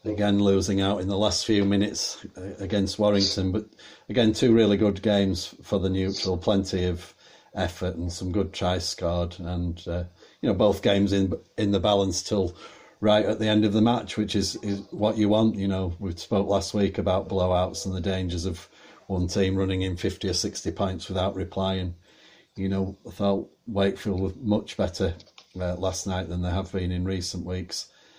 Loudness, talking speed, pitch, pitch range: -26 LUFS, 195 wpm, 95 Hz, 90-100 Hz